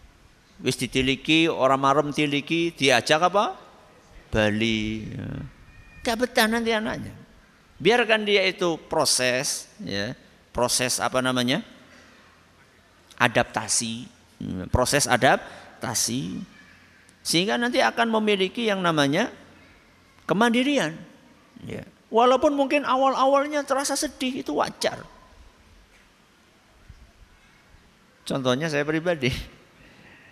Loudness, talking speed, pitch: -23 LUFS, 85 wpm, 150 Hz